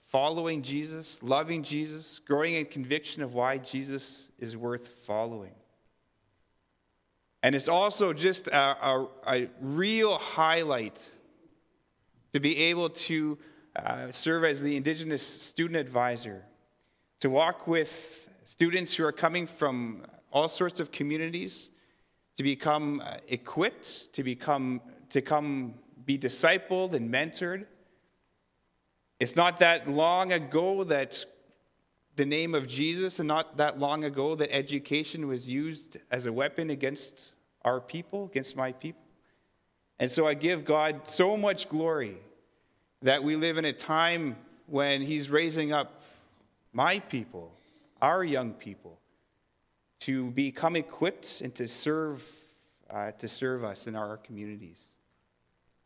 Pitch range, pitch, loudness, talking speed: 130-160 Hz, 145 Hz, -29 LUFS, 130 wpm